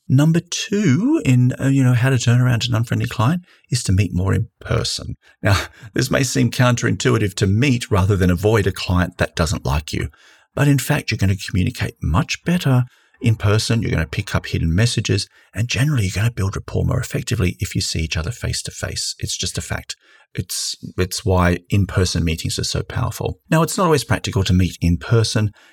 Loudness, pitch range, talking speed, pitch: -19 LUFS, 95-130 Hz, 210 wpm, 115 Hz